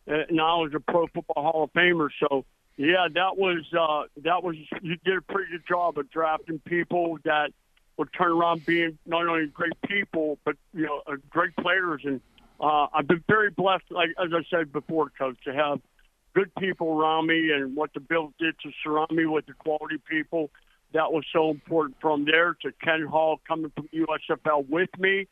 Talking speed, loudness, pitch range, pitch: 205 wpm, -26 LUFS, 150-170 Hz, 160 Hz